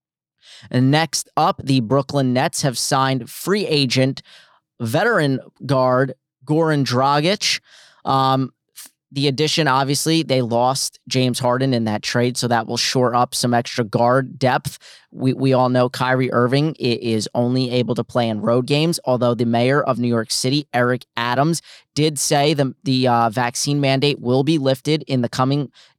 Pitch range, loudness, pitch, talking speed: 120-145 Hz, -19 LUFS, 130 Hz, 160 wpm